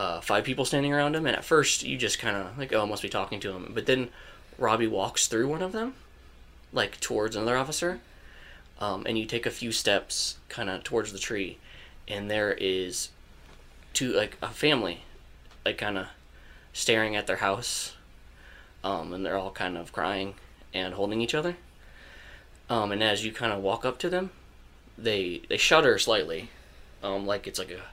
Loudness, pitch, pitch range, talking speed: -28 LUFS, 100 Hz, 80-115 Hz, 190 wpm